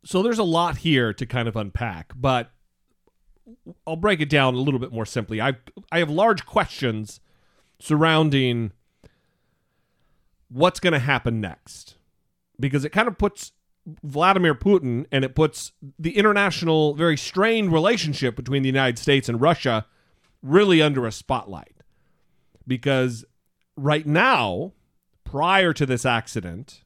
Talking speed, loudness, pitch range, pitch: 140 wpm, -21 LUFS, 125-170 Hz, 140 Hz